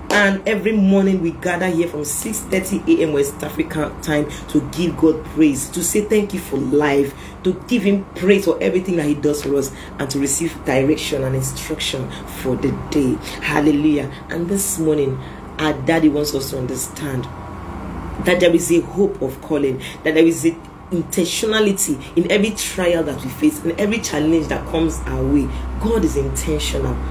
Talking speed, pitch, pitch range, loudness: 180 wpm, 155 Hz, 140-180 Hz, -19 LUFS